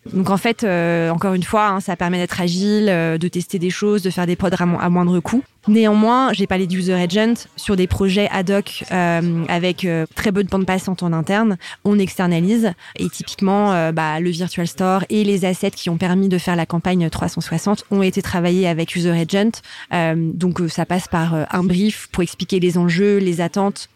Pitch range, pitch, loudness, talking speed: 175-200 Hz, 185 Hz, -18 LUFS, 210 wpm